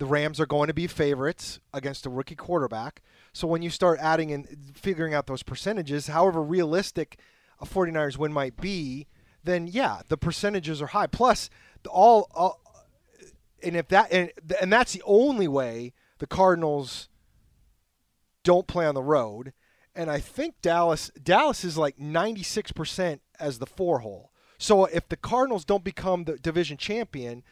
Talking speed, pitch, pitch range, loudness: 160 wpm, 165 Hz, 145-185 Hz, -26 LUFS